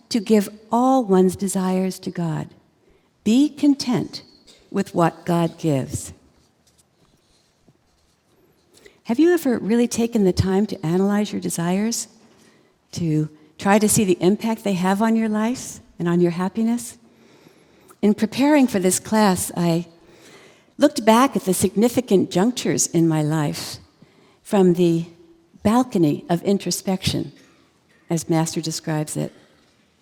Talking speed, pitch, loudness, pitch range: 125 wpm, 190 Hz, -20 LUFS, 170-225 Hz